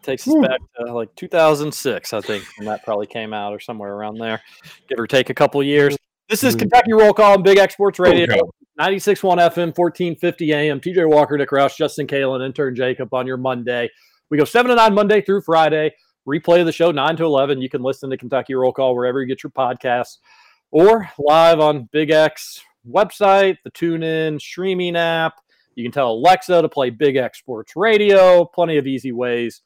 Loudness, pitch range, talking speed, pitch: -17 LUFS, 130-180 Hz, 200 wpm, 155 Hz